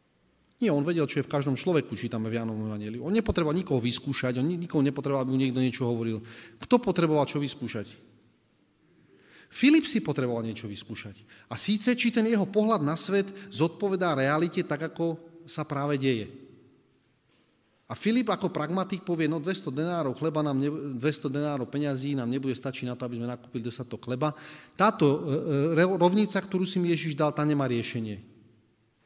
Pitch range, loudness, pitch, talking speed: 120-170 Hz, -27 LUFS, 145 Hz, 165 wpm